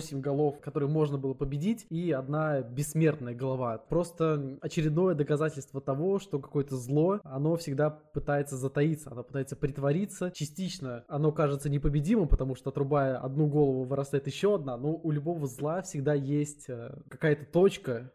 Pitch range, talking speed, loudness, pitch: 135-155 Hz, 145 wpm, -30 LUFS, 145 Hz